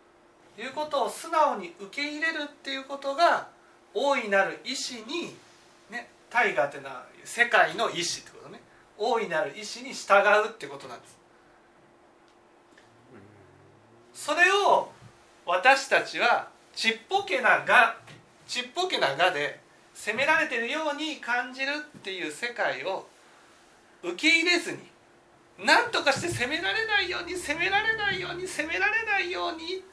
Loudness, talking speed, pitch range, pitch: -26 LUFS, 275 characters per minute, 220-340 Hz, 285 Hz